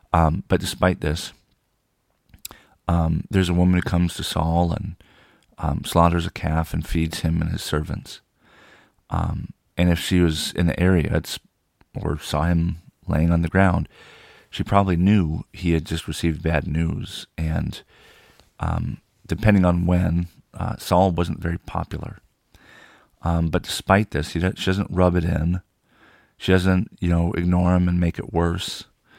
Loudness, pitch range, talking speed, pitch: -22 LUFS, 80-90 Hz, 160 wpm, 85 Hz